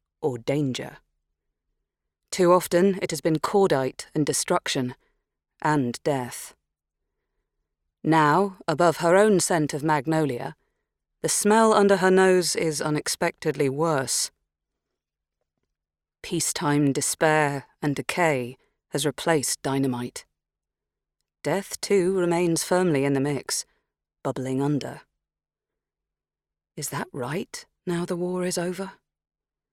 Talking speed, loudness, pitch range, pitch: 105 wpm, -24 LUFS, 140-180 Hz, 160 Hz